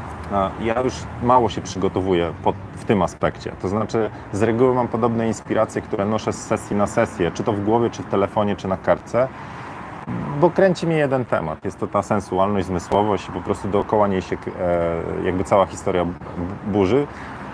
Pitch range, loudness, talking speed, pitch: 95-115 Hz, -21 LUFS, 175 wpm, 105 Hz